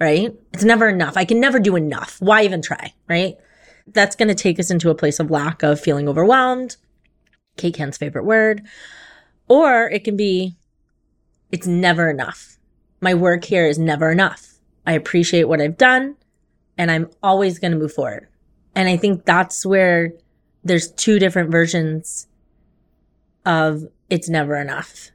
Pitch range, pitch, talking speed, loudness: 160-200 Hz, 175 Hz, 160 wpm, -17 LUFS